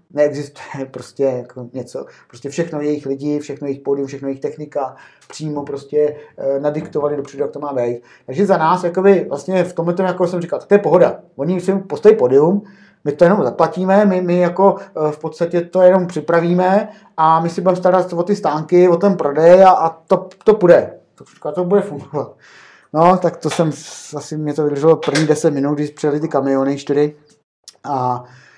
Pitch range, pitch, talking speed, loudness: 145-180 Hz, 160 Hz, 185 wpm, -16 LUFS